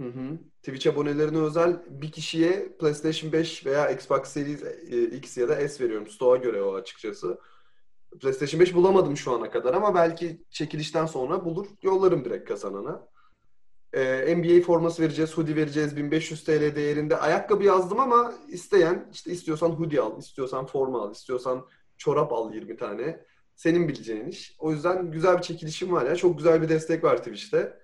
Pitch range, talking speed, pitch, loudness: 150-185 Hz, 165 wpm, 165 Hz, -25 LUFS